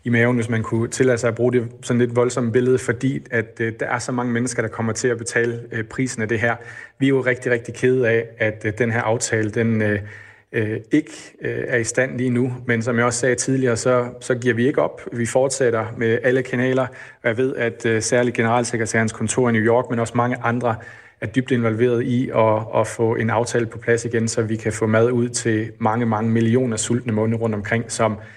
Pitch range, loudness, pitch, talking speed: 115-125 Hz, -20 LUFS, 120 Hz, 240 wpm